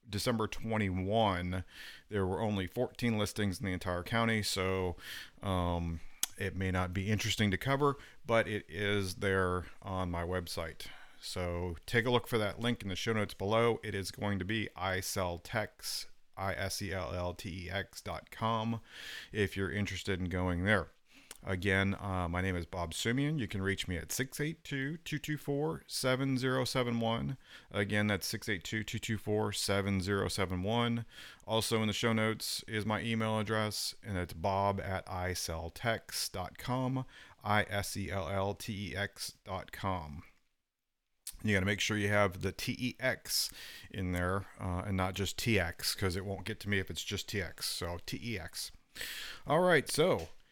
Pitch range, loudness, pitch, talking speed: 95-110 Hz, -35 LUFS, 100 Hz, 145 wpm